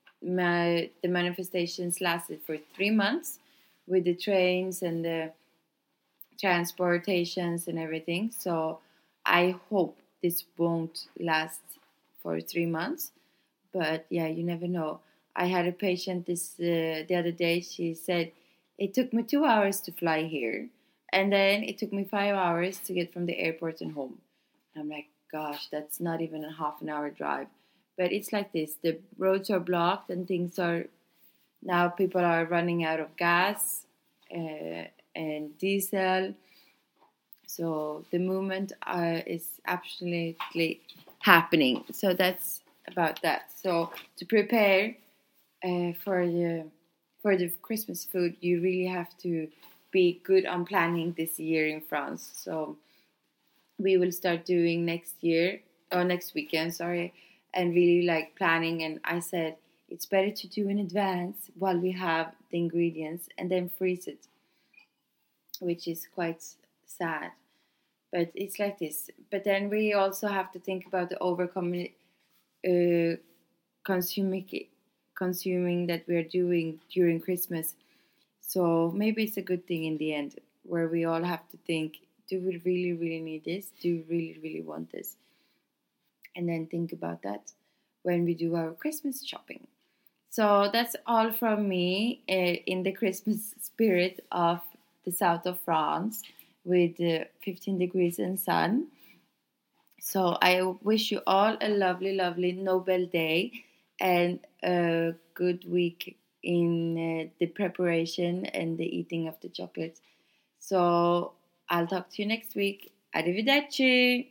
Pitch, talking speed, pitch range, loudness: 175 Hz, 145 wpm, 165-190 Hz, -29 LUFS